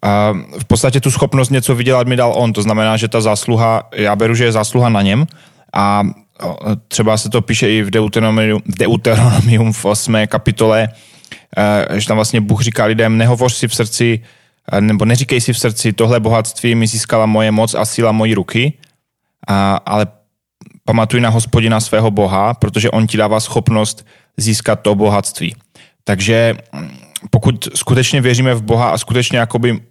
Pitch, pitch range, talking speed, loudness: 115 Hz, 110-120 Hz, 165 wpm, -13 LUFS